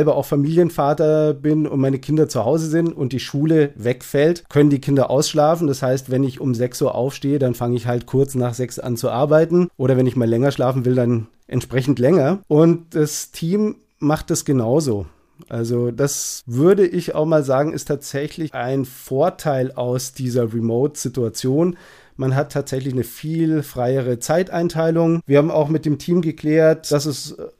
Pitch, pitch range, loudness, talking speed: 140 Hz, 130-155 Hz, -19 LUFS, 175 wpm